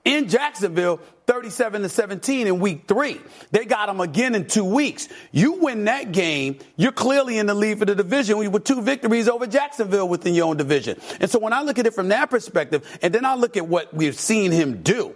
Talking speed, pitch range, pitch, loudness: 220 wpm, 180-245 Hz, 215 Hz, -21 LUFS